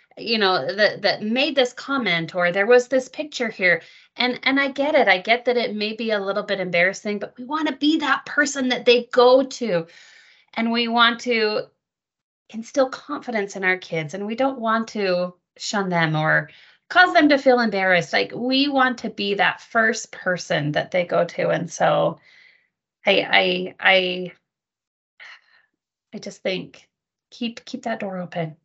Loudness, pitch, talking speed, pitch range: -20 LUFS, 225 Hz, 180 wpm, 185-260 Hz